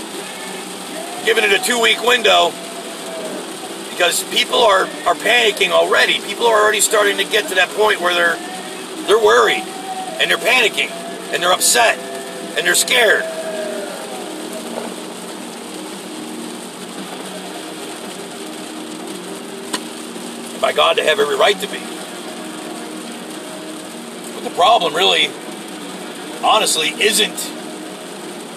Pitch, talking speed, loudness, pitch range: 375 Hz, 100 wpm, -15 LUFS, 245-410 Hz